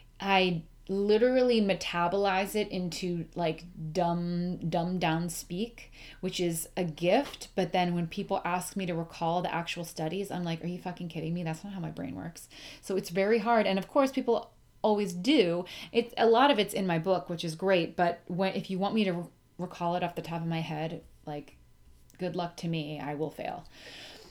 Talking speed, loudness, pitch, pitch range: 205 wpm, -30 LUFS, 180 Hz, 170-195 Hz